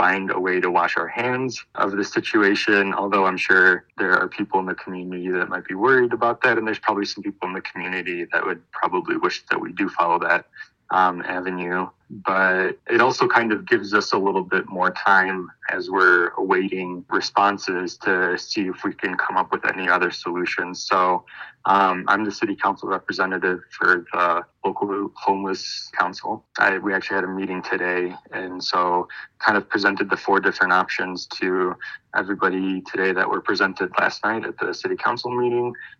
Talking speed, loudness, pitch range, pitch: 185 wpm, -21 LUFS, 90-120 Hz, 95 Hz